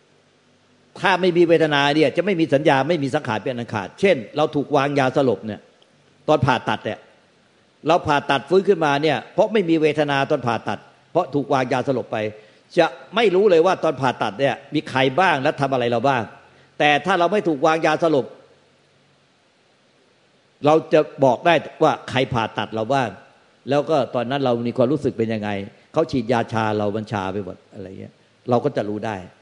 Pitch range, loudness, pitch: 115-155 Hz, -20 LUFS, 140 Hz